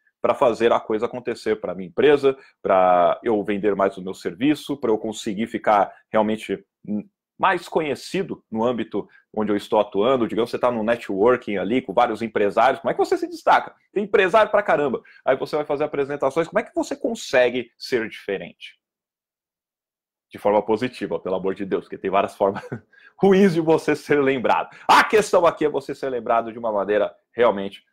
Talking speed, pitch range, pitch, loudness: 185 wpm, 105-150 Hz, 120 Hz, -21 LUFS